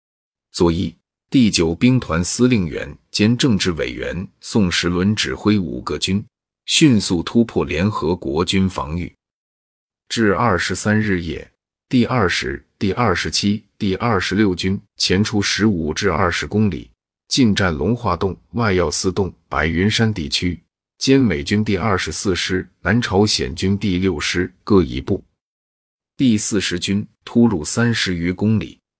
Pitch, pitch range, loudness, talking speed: 95 Hz, 85-110 Hz, -18 LUFS, 210 characters per minute